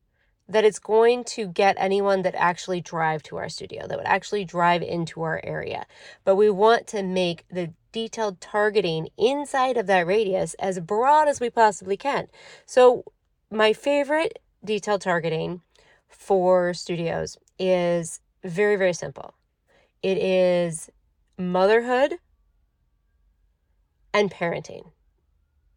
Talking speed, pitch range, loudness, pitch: 125 wpm, 170-220 Hz, -23 LUFS, 190 Hz